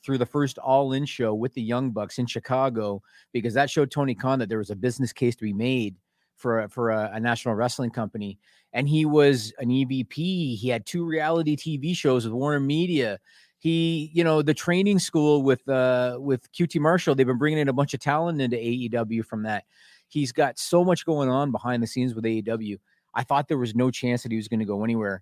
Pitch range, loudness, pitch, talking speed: 115-145 Hz, -25 LUFS, 130 Hz, 220 wpm